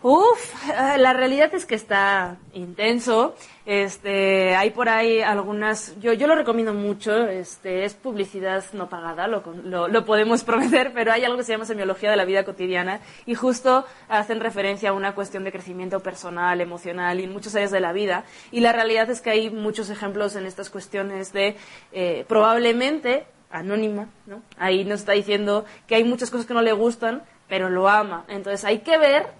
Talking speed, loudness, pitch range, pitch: 185 wpm, -22 LUFS, 195-230 Hz, 210 Hz